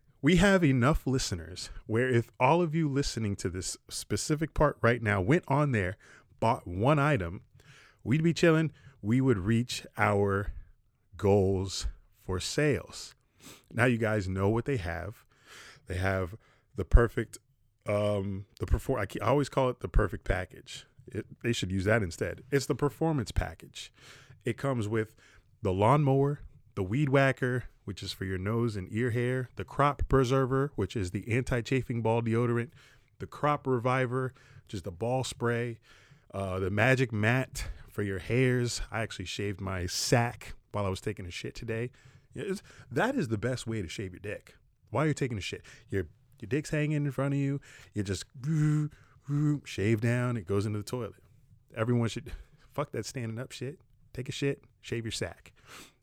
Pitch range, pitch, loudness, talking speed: 100-135 Hz, 120 Hz, -30 LUFS, 175 wpm